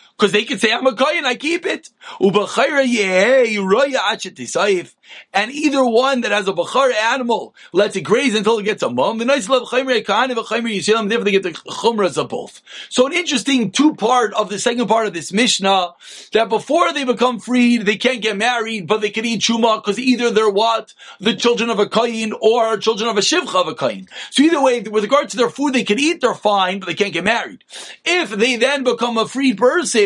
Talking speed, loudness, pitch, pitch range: 200 wpm, -17 LUFS, 230 Hz, 210-255 Hz